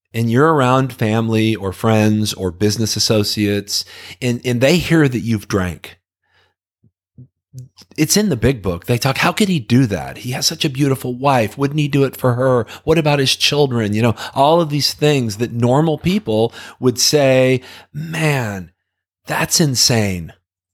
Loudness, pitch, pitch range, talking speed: -16 LUFS, 125 Hz, 105-145 Hz, 170 wpm